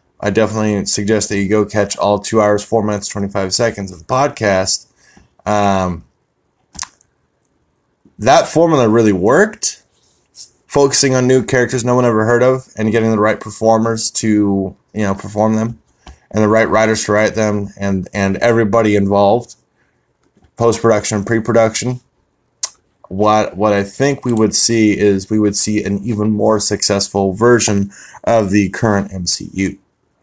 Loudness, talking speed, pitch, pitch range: -14 LUFS, 150 wpm, 105 Hz, 100-115 Hz